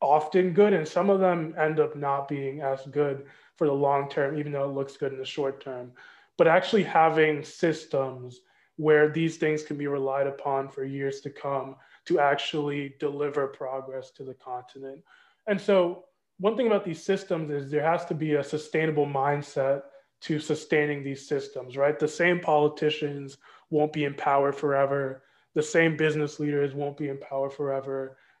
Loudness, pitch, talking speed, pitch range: -27 LUFS, 145 Hz, 175 wpm, 140-155 Hz